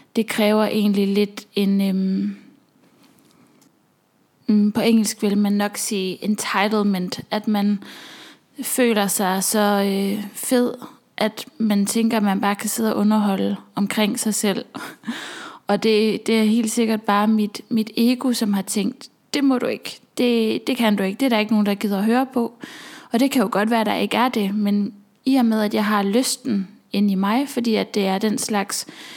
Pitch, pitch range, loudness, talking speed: 215 Hz, 205-245 Hz, -20 LUFS, 190 wpm